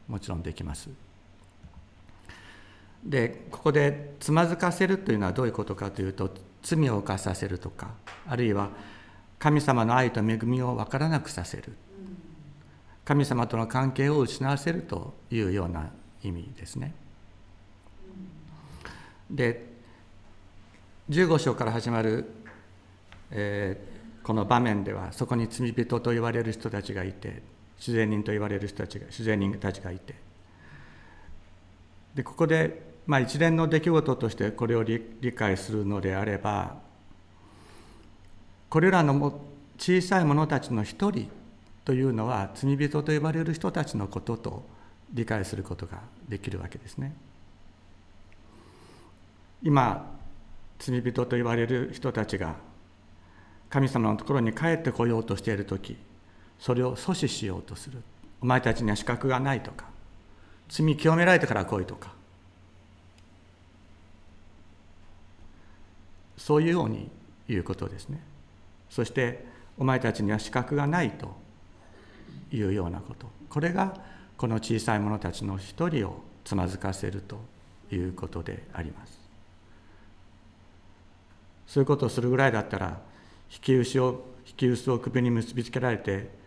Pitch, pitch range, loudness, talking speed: 105 Hz, 95-125 Hz, -28 LUFS, 260 characters per minute